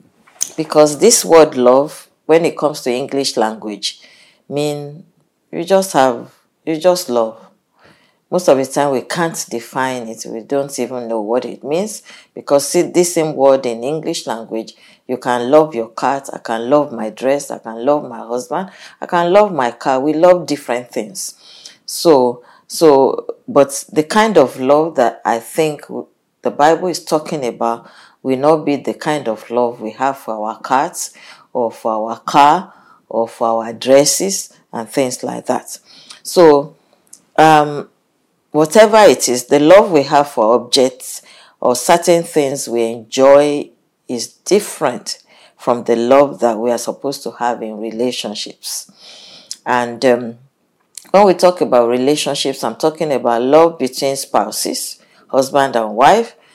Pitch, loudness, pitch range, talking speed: 135 Hz, -15 LUFS, 120-155 Hz, 155 wpm